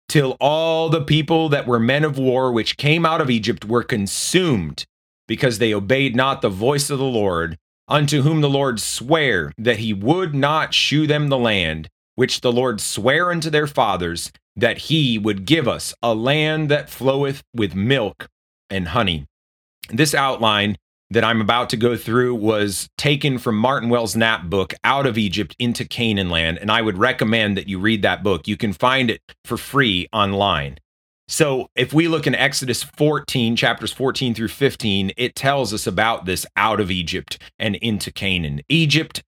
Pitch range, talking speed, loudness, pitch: 100-135 Hz, 180 wpm, -19 LUFS, 115 Hz